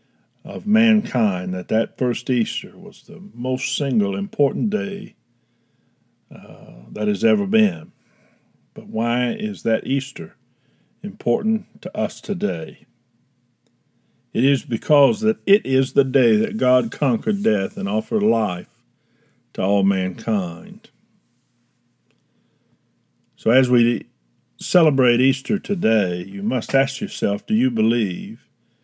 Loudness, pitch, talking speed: -20 LUFS, 140 Hz, 120 wpm